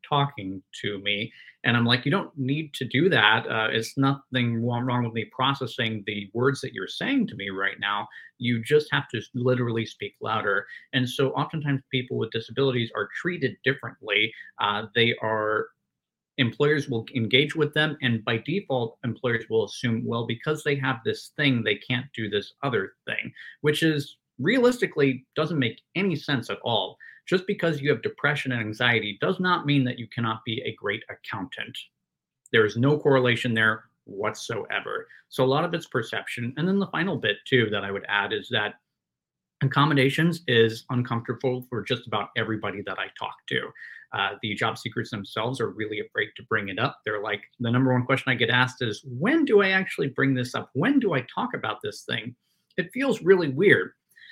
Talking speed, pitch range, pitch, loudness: 190 wpm, 115-145 Hz, 125 Hz, -25 LUFS